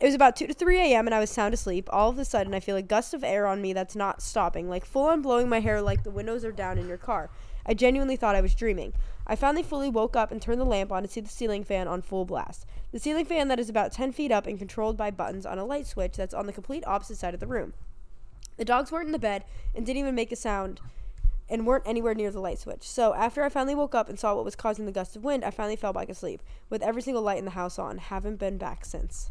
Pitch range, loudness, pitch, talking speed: 195-250 Hz, -28 LUFS, 220 Hz, 290 wpm